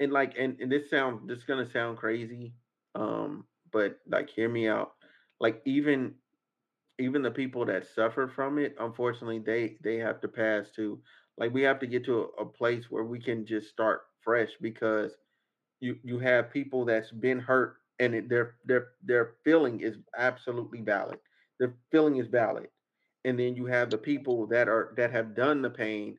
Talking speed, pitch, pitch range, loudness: 190 wpm, 120 Hz, 115-130 Hz, -30 LUFS